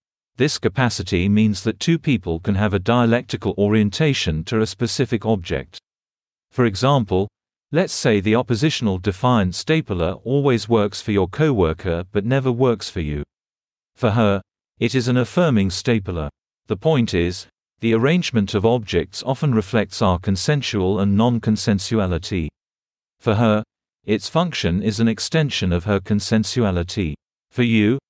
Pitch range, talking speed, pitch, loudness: 95-120 Hz, 140 wpm, 110 Hz, -20 LUFS